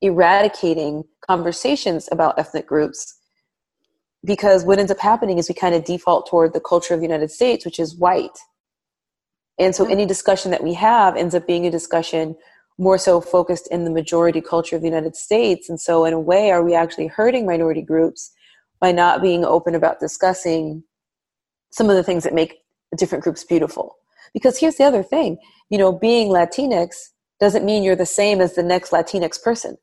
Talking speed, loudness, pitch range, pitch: 190 wpm, -18 LUFS, 165-195 Hz, 175 Hz